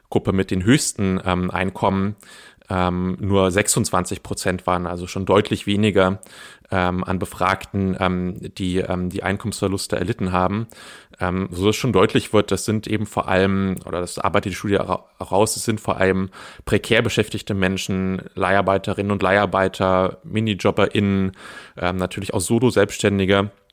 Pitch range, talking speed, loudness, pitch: 95-105 Hz, 145 wpm, -21 LUFS, 95 Hz